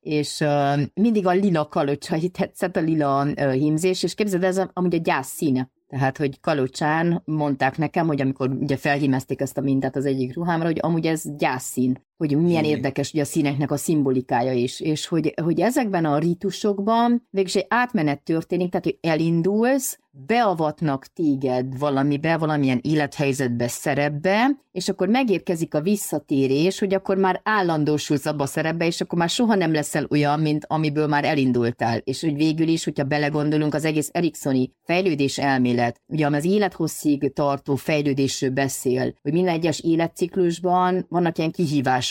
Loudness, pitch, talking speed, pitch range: -22 LUFS, 155 Hz, 160 wpm, 140-175 Hz